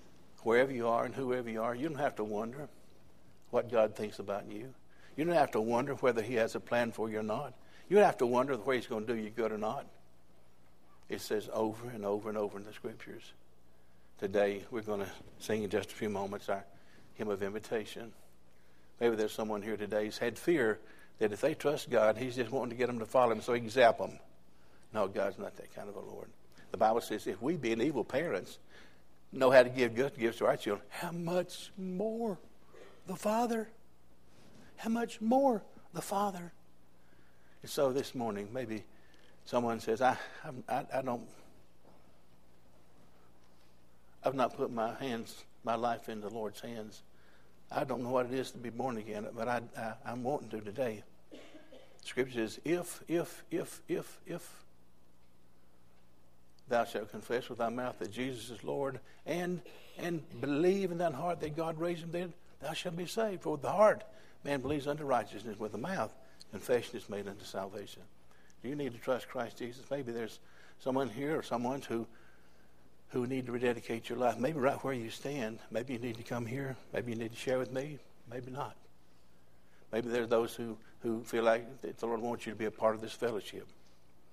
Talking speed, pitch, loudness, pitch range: 200 wpm, 115 Hz, -35 LUFS, 95-130 Hz